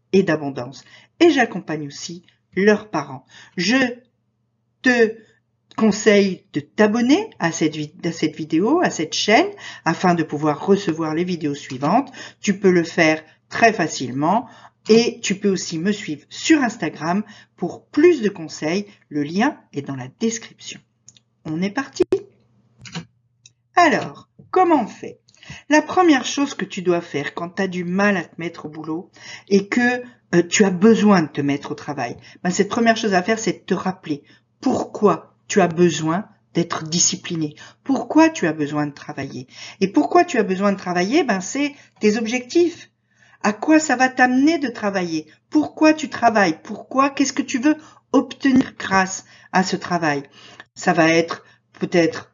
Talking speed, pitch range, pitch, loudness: 165 wpm, 155-245 Hz, 190 Hz, -19 LUFS